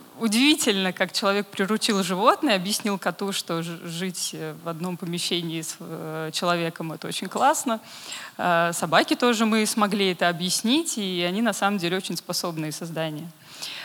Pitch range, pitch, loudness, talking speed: 170-220 Hz, 185 Hz, -24 LUFS, 135 wpm